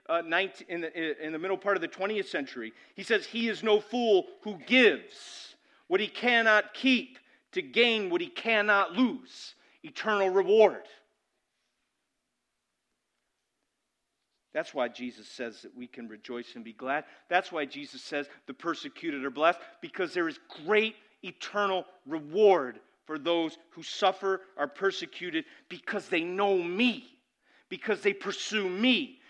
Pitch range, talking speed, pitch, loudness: 160-235 Hz, 145 wpm, 195 Hz, -28 LUFS